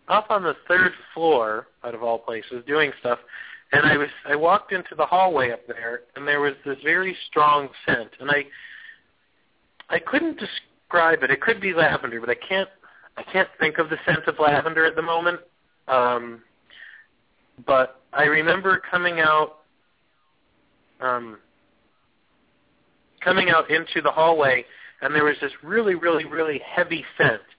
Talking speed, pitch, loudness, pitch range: 155 wpm, 160 Hz, -21 LUFS, 135-180 Hz